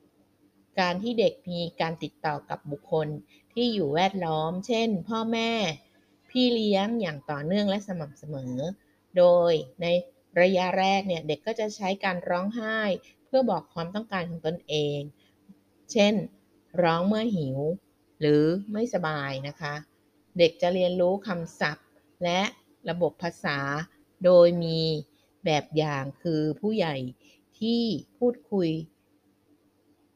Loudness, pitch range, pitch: -27 LUFS, 150-200 Hz, 175 Hz